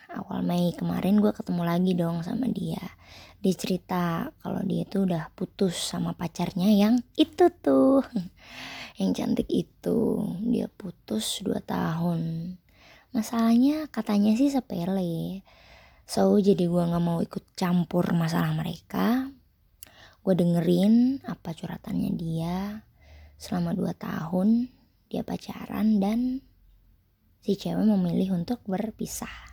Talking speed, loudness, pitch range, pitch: 115 wpm, -27 LUFS, 175-220 Hz, 195 Hz